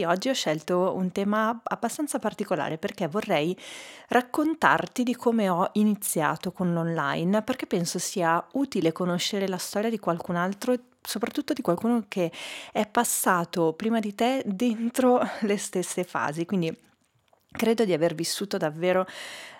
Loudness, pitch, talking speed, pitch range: -26 LUFS, 200 Hz, 140 wpm, 175-235 Hz